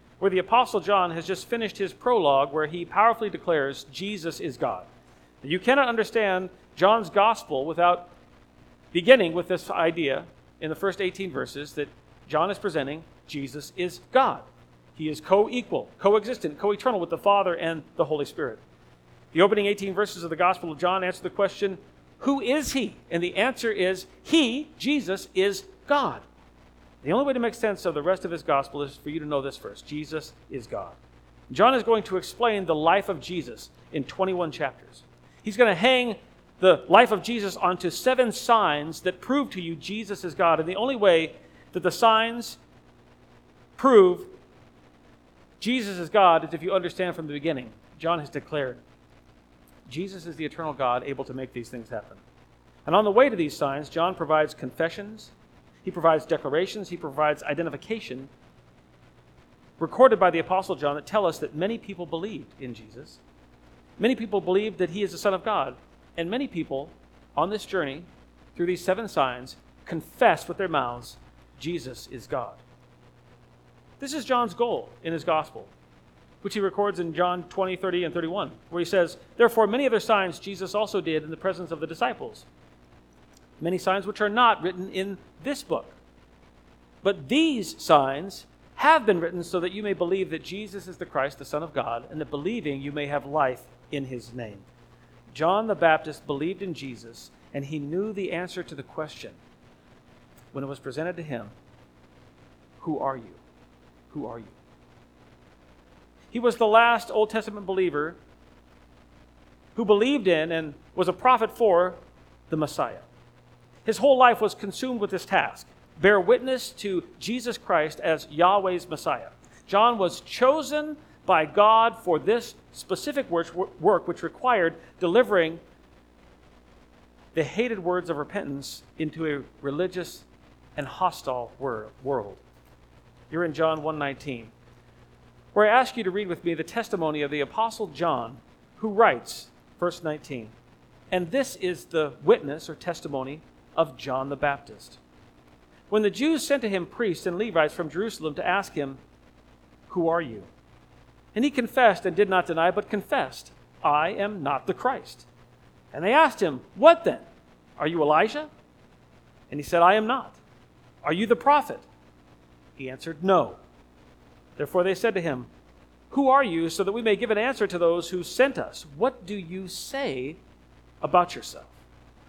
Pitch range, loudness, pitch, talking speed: 135-205 Hz, -25 LUFS, 175 Hz, 170 wpm